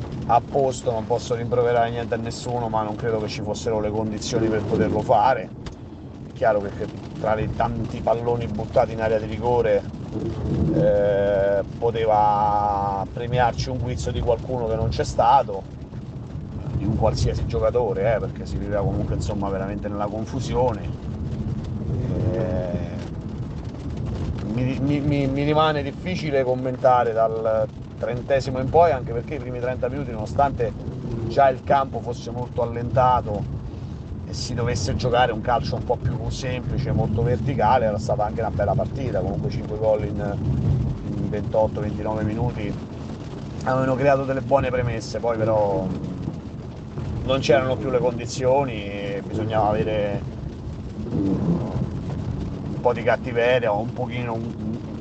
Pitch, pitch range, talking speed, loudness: 115 Hz, 110-125 Hz, 140 wpm, -23 LUFS